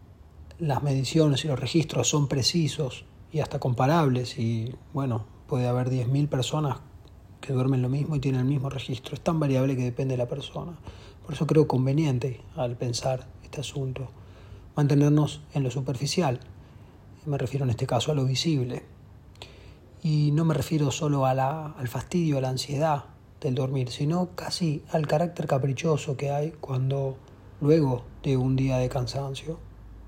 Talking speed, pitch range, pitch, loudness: 160 wpm, 125-150 Hz, 135 Hz, -27 LUFS